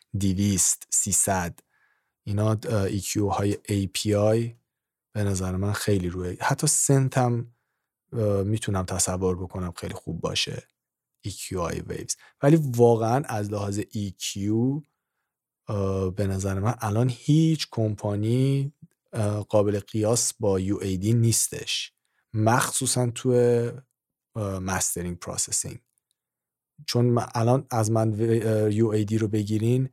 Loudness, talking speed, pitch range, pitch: -25 LUFS, 105 wpm, 100-120 Hz, 110 Hz